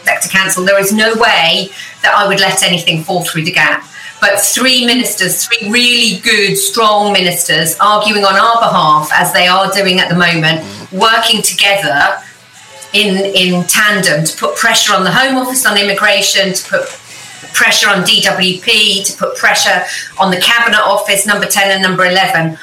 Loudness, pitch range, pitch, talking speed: -9 LUFS, 185-215 Hz, 195 Hz, 170 wpm